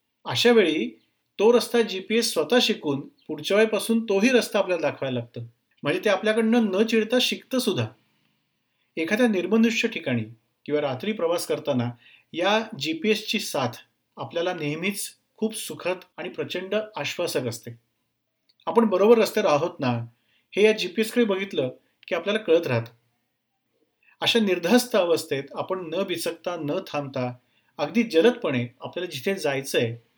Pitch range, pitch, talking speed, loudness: 130-215 Hz, 180 Hz, 140 wpm, -24 LUFS